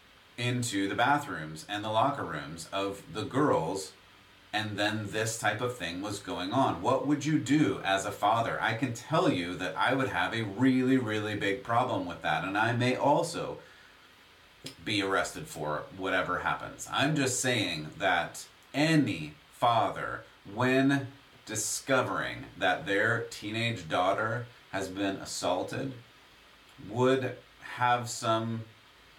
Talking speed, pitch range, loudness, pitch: 140 wpm, 100-130 Hz, -30 LUFS, 115 Hz